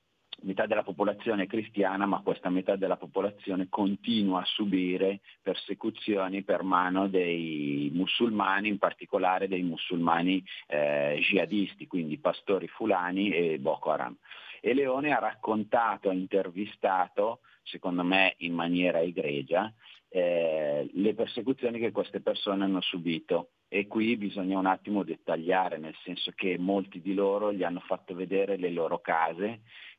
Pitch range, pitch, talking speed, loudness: 90-100 Hz, 95 Hz, 135 wpm, -29 LUFS